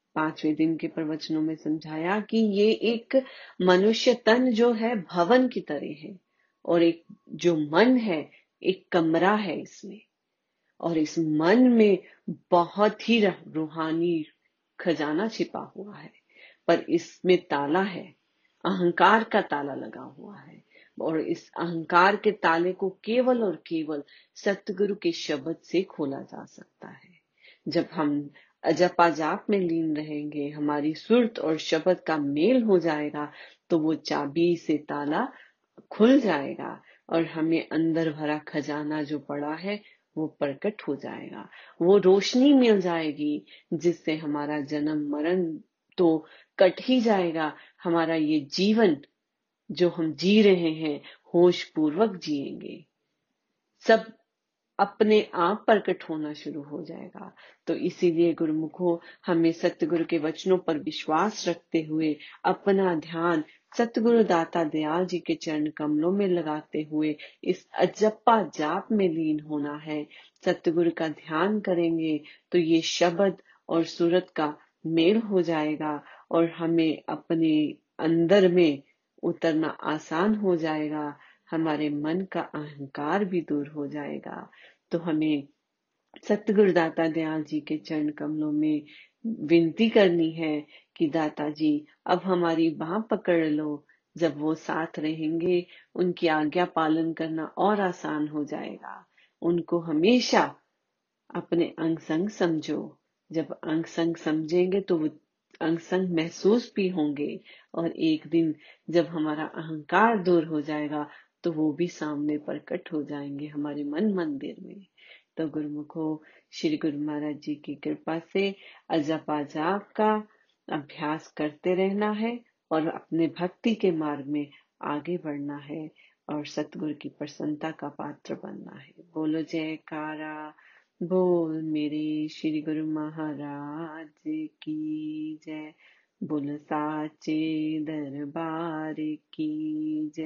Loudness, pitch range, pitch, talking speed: -26 LUFS, 155-185 Hz, 165 Hz, 130 wpm